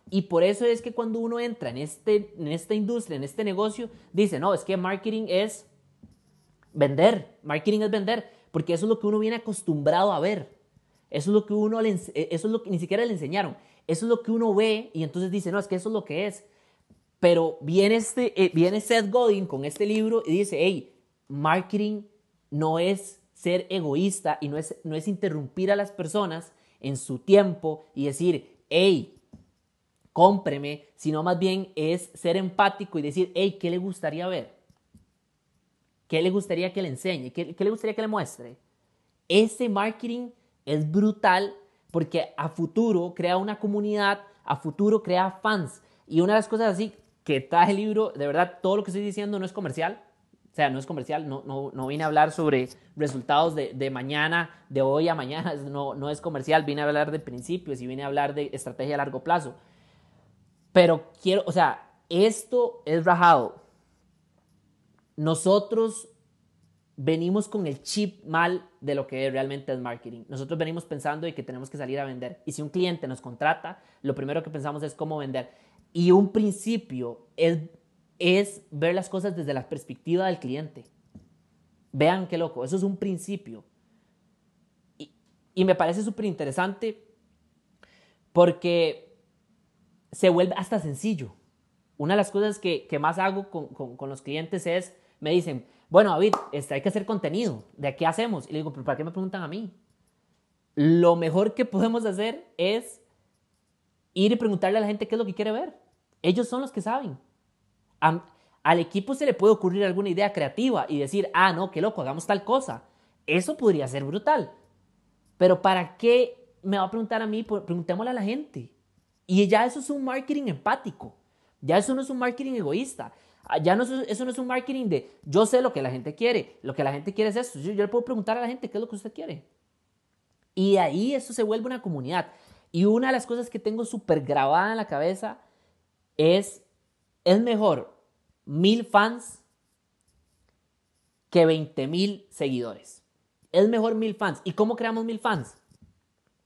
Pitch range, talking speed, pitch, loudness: 150-210 Hz, 185 wpm, 185 Hz, -26 LUFS